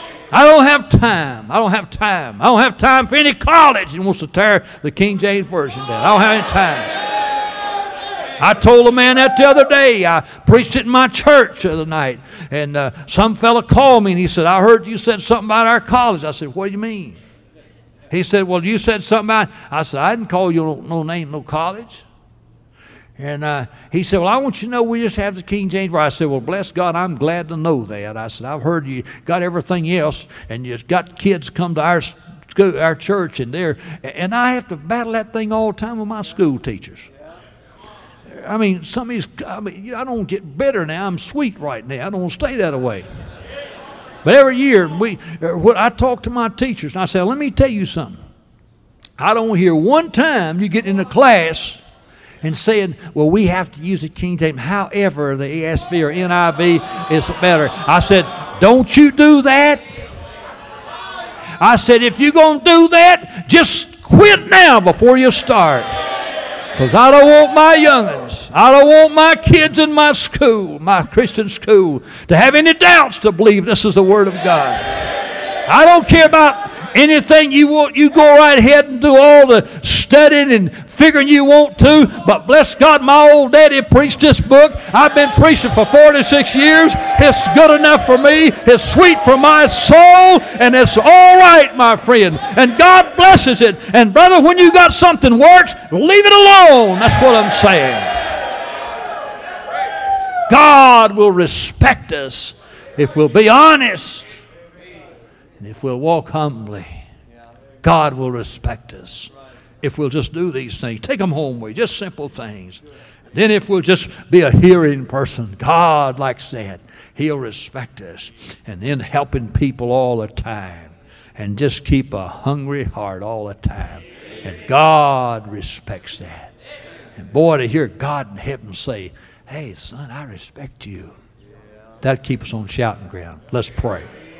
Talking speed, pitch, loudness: 190 wpm, 195 Hz, -10 LUFS